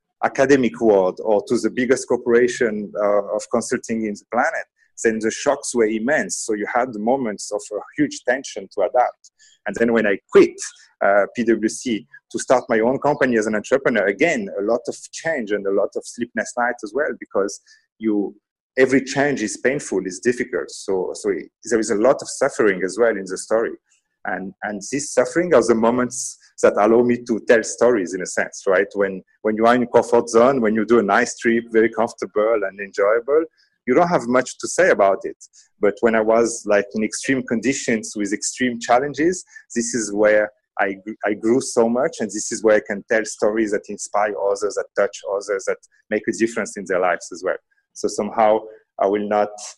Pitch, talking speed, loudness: 120 Hz, 205 wpm, -20 LUFS